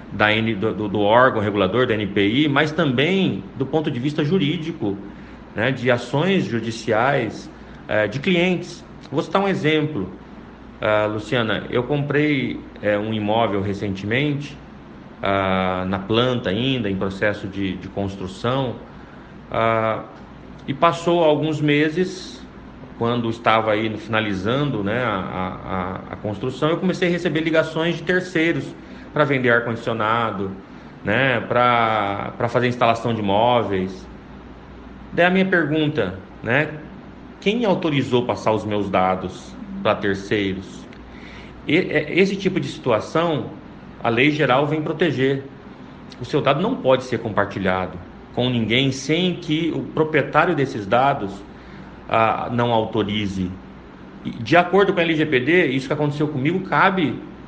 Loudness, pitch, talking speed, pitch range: -20 LUFS, 120 Hz, 130 wpm, 105-155 Hz